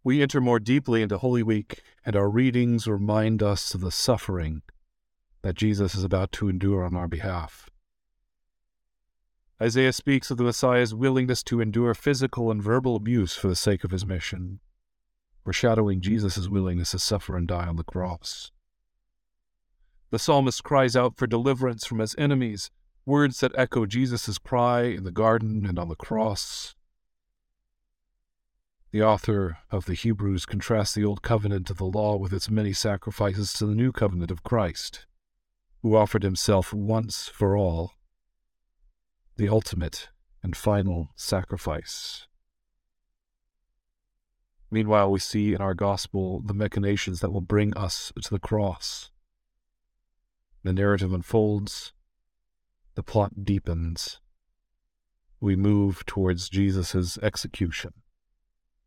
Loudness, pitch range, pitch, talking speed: -26 LUFS, 95-115 Hz, 105 Hz, 135 wpm